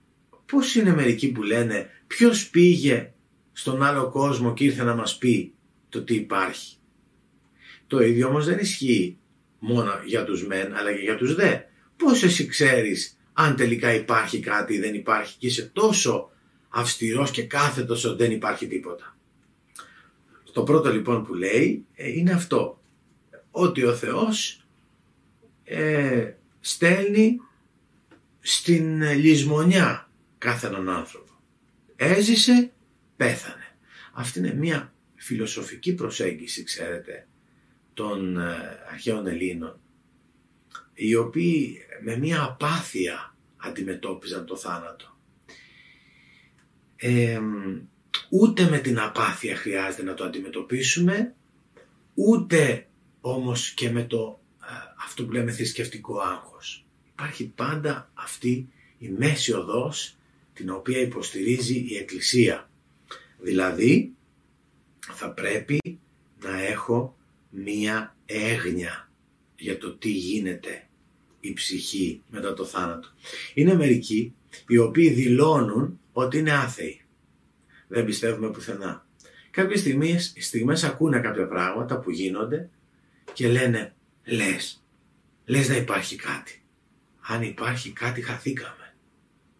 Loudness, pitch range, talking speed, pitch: -24 LUFS, 105-150 Hz, 110 wpm, 120 Hz